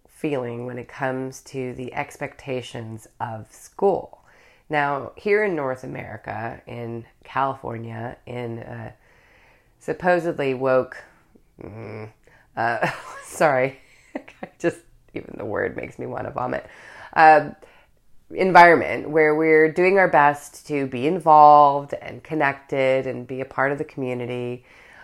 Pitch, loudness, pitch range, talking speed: 130 Hz, -20 LUFS, 120-150 Hz, 120 wpm